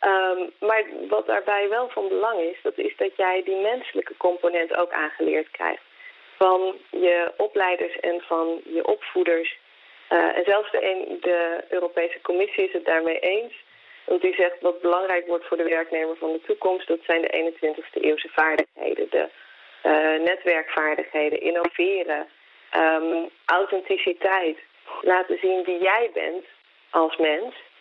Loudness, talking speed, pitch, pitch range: -23 LUFS, 145 wpm, 175 Hz, 165-195 Hz